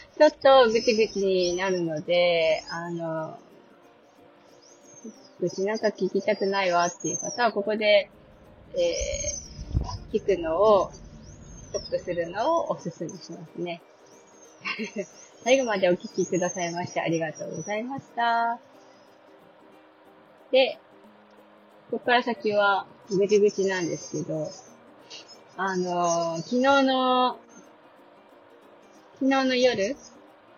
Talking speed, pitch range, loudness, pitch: 210 characters per minute, 175-240 Hz, -25 LUFS, 200 Hz